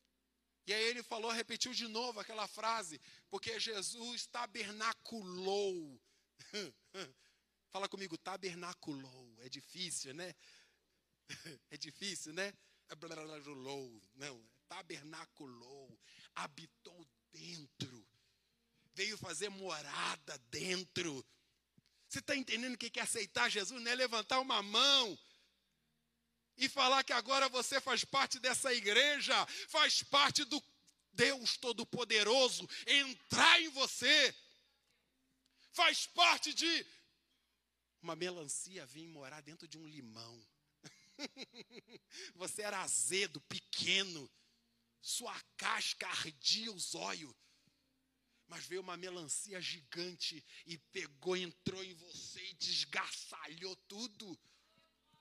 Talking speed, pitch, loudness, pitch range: 100 wpm, 190 Hz, -36 LUFS, 155-240 Hz